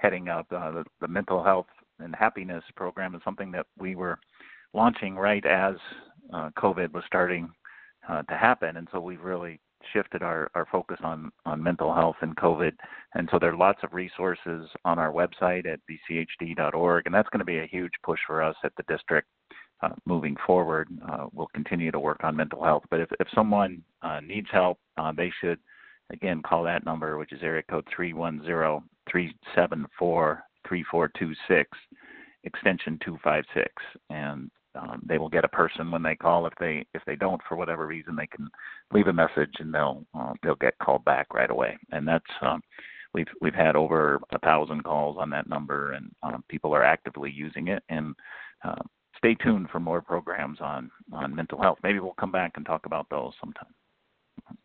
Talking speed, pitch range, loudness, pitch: 195 wpm, 80-90 Hz, -28 LUFS, 85 Hz